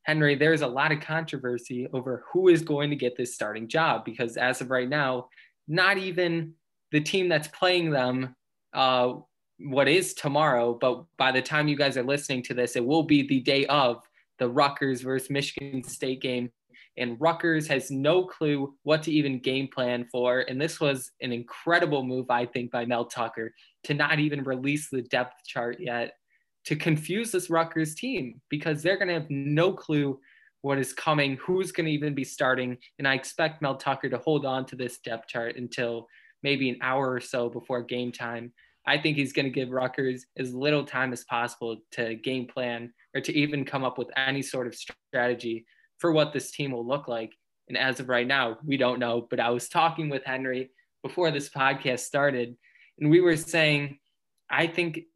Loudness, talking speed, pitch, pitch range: -27 LUFS, 195 wpm, 135 Hz, 125-150 Hz